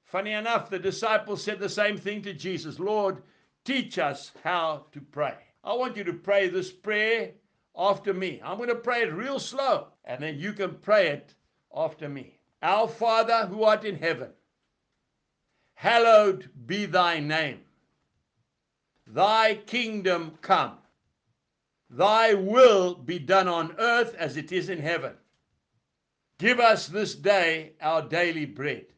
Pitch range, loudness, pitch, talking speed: 165-220 Hz, -25 LUFS, 195 Hz, 145 wpm